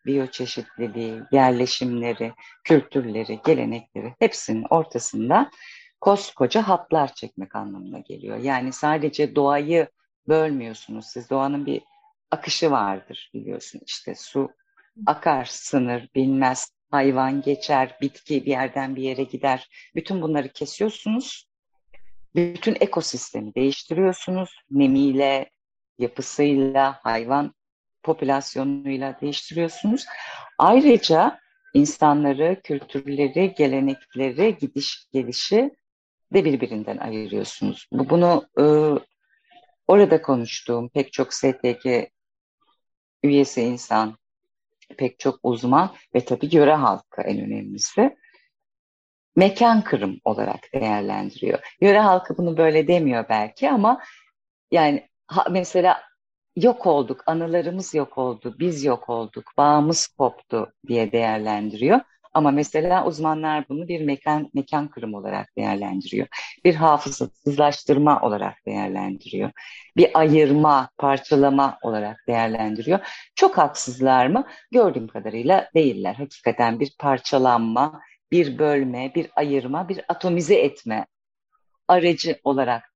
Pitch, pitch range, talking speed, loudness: 145 Hz, 125-175 Hz, 100 wpm, -21 LUFS